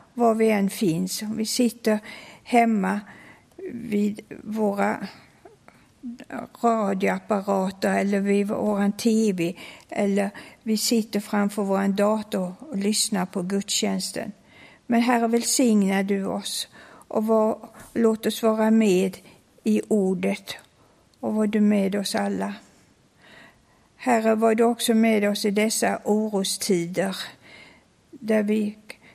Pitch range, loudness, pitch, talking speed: 200-225 Hz, -23 LUFS, 210 Hz, 110 wpm